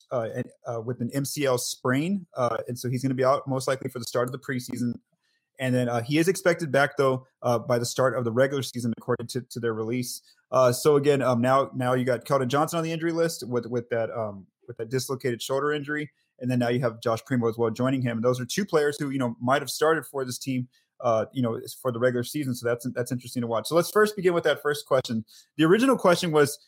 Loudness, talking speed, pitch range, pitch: -26 LUFS, 265 wpm, 120-145 Hz, 130 Hz